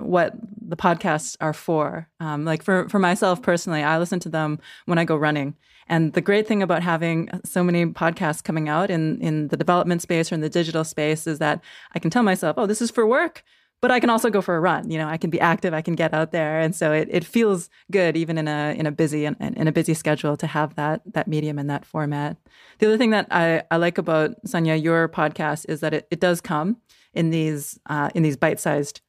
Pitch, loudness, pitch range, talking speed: 165 Hz, -22 LUFS, 155-185 Hz, 245 wpm